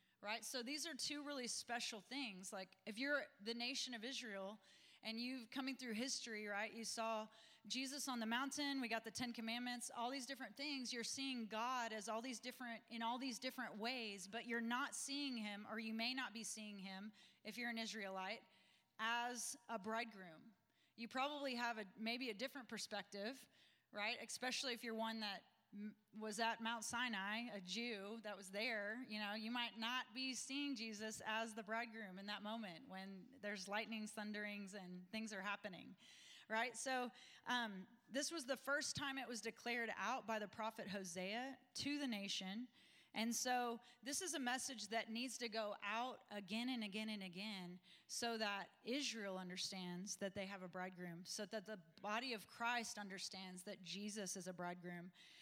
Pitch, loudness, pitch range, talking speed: 225 Hz, -47 LUFS, 205-245 Hz, 180 wpm